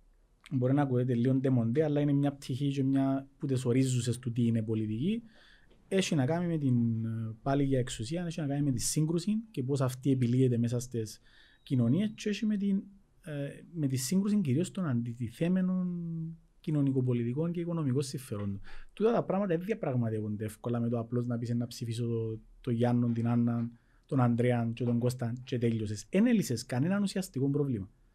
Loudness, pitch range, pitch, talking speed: -31 LUFS, 120-165 Hz, 130 Hz, 175 wpm